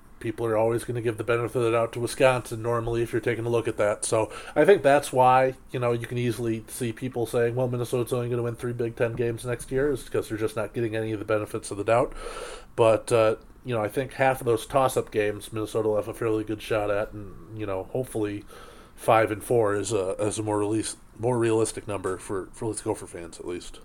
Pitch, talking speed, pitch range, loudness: 115 Hz, 255 wpm, 110-125 Hz, -26 LUFS